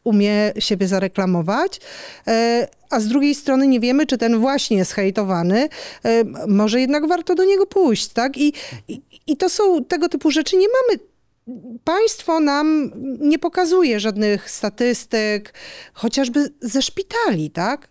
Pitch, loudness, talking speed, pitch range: 265 Hz, -18 LUFS, 135 wpm, 215-325 Hz